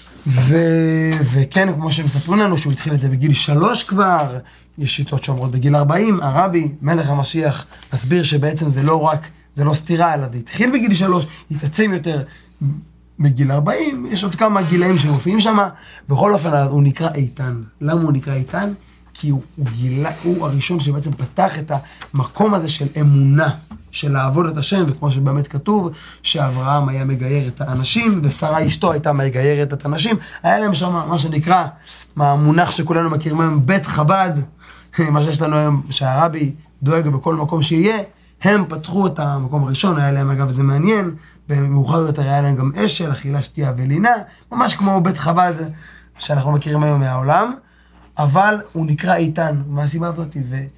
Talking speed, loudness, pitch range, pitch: 165 wpm, -17 LUFS, 140-170 Hz, 150 Hz